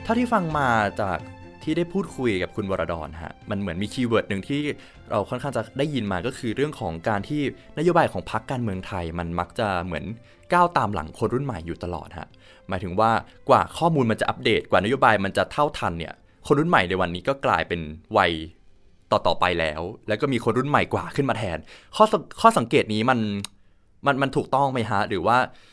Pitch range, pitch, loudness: 90-130 Hz, 105 Hz, -24 LUFS